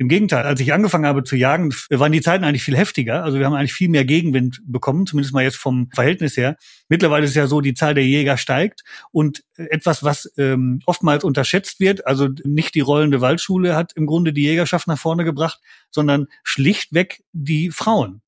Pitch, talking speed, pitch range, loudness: 150 Hz, 200 wpm, 140-170 Hz, -18 LUFS